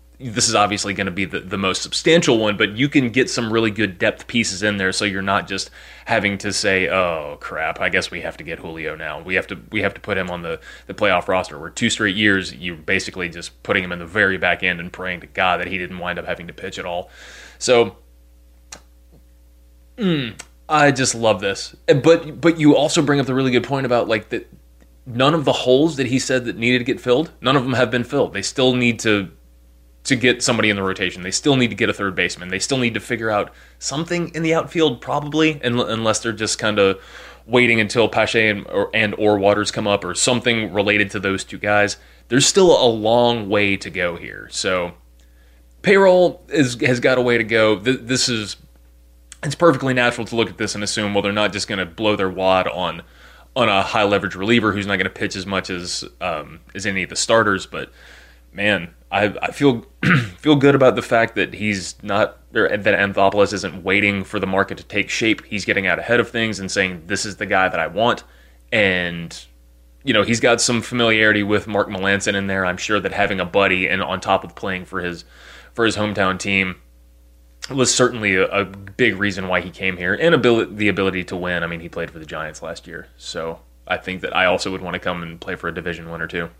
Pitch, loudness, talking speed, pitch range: 100 Hz, -19 LUFS, 235 wpm, 90-120 Hz